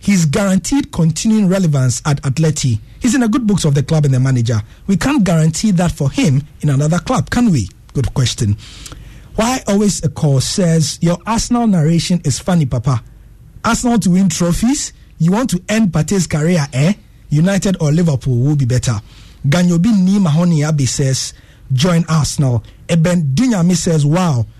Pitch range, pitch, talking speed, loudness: 135-190 Hz, 160 Hz, 165 wpm, -15 LUFS